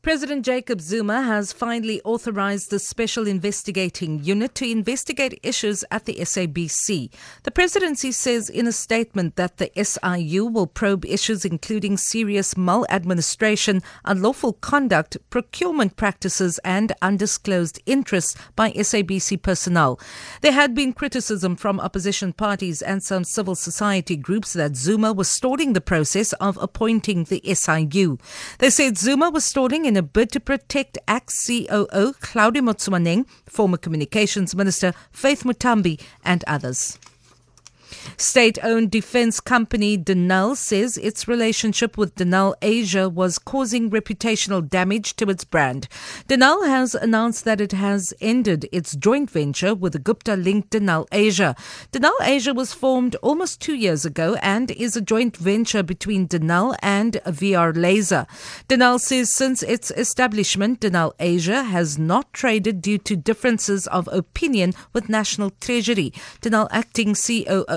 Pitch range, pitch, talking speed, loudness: 185-235 Hz, 210 Hz, 135 wpm, -20 LUFS